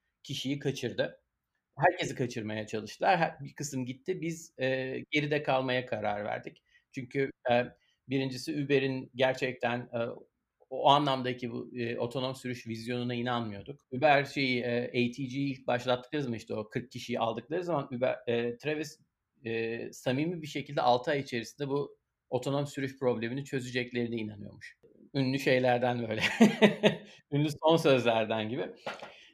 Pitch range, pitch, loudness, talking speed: 120-145 Hz, 130 Hz, -31 LUFS, 135 wpm